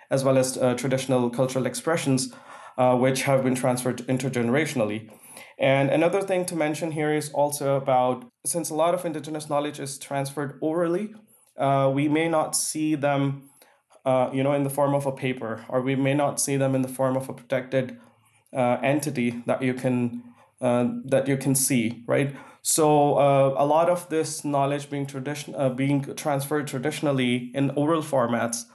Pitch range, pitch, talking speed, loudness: 130-150 Hz, 135 Hz, 175 wpm, -24 LUFS